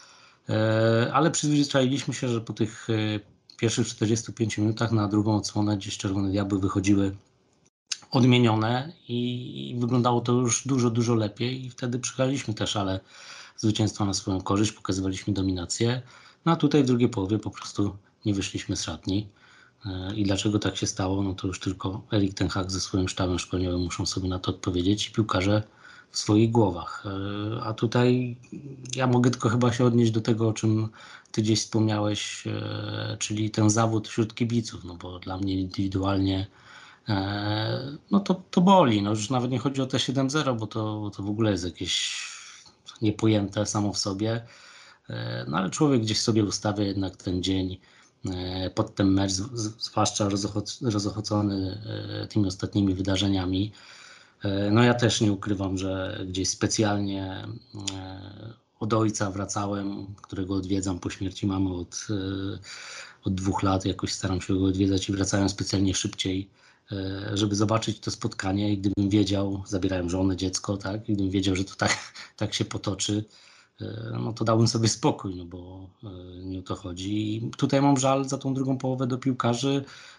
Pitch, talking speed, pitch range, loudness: 105 Hz, 155 wpm, 95-115 Hz, -26 LUFS